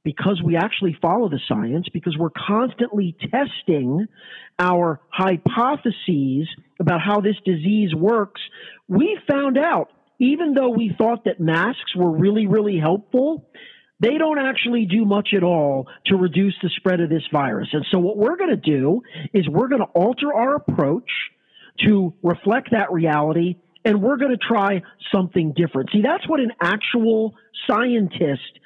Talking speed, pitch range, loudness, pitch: 155 wpm, 170-235 Hz, -20 LUFS, 200 Hz